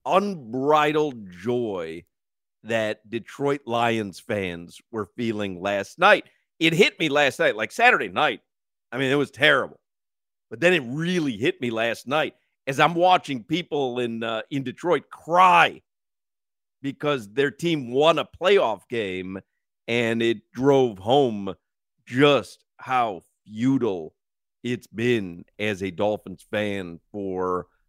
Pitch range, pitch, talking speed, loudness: 105-140 Hz, 120 Hz, 130 wpm, -23 LUFS